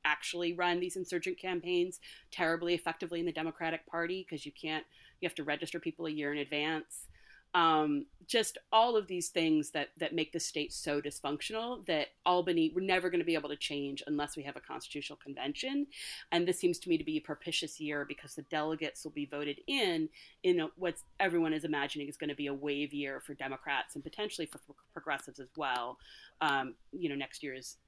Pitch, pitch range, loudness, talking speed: 160 Hz, 145-180 Hz, -35 LUFS, 200 wpm